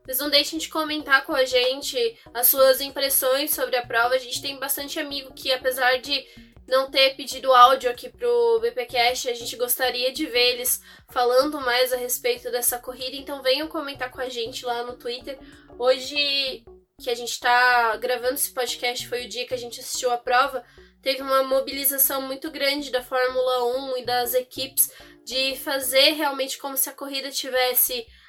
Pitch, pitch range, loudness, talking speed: 265 Hz, 250-285 Hz, -22 LUFS, 185 wpm